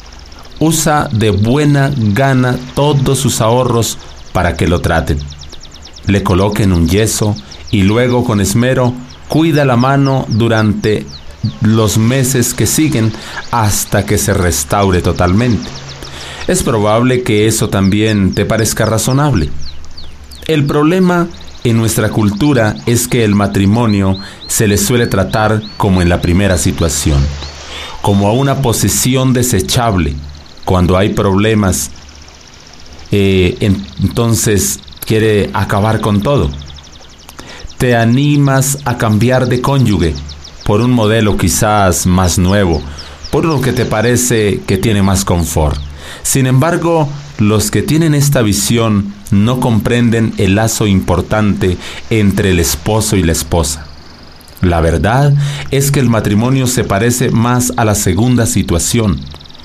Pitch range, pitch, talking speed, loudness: 85-120 Hz, 105 Hz, 125 wpm, -12 LUFS